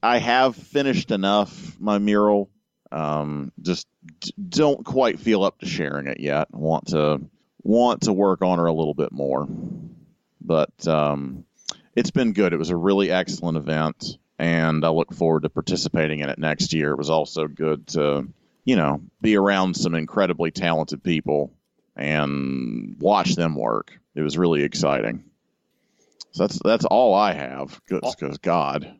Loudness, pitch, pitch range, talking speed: -22 LUFS, 80 Hz, 75-95 Hz, 160 wpm